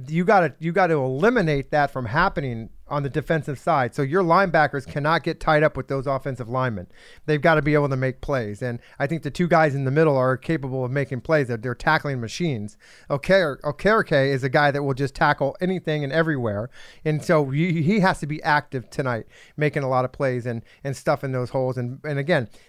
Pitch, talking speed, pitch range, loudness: 145 Hz, 220 wpm, 130-160 Hz, -22 LUFS